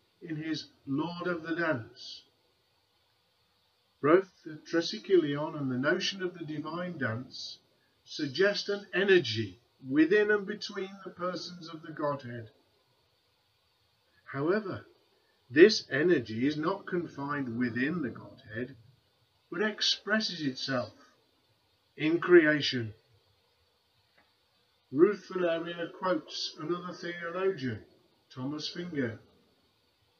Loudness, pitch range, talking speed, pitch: -30 LUFS, 125-180 Hz, 95 wpm, 155 Hz